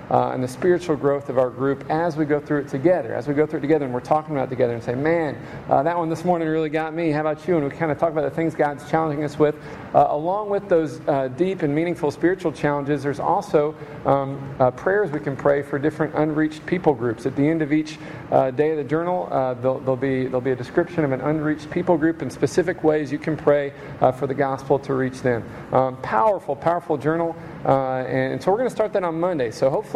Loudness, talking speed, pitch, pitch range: -22 LUFS, 255 wpm, 150 Hz, 135-160 Hz